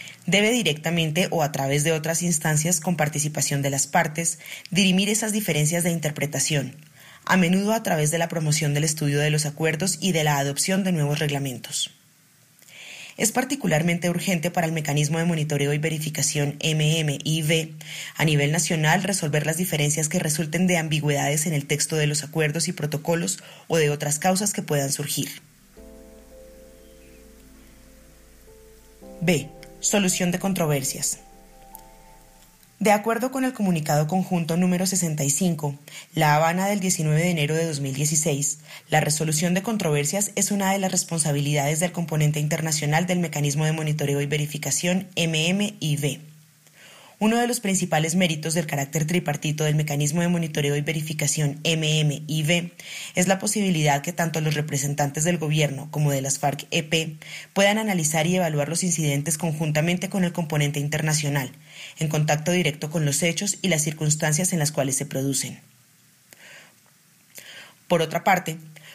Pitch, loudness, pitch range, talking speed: 155 Hz, -23 LUFS, 145-175 Hz, 145 wpm